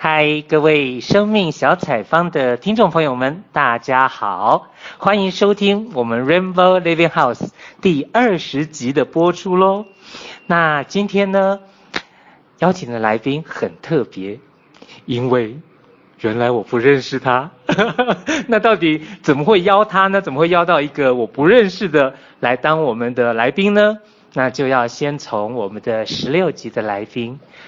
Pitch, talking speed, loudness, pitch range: 155 Hz, 245 characters per minute, -16 LUFS, 125-195 Hz